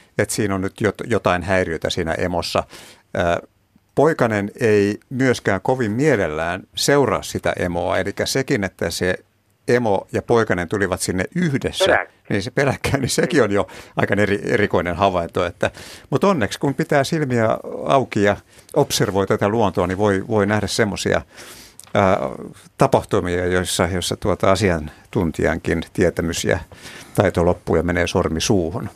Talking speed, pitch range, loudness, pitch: 135 wpm, 90-120 Hz, -20 LUFS, 100 Hz